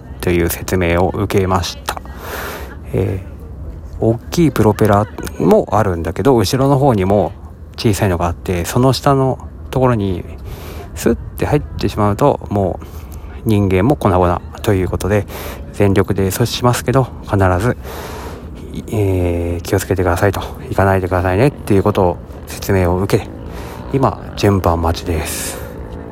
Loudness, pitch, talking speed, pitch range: -16 LUFS, 95 Hz, 285 characters per minute, 85-105 Hz